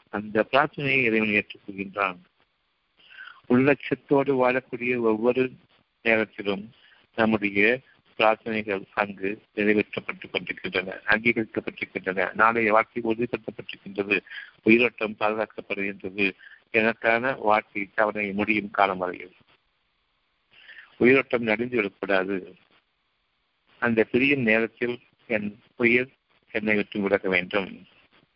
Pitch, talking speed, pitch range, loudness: 110 Hz, 60 wpm, 100-120 Hz, -24 LUFS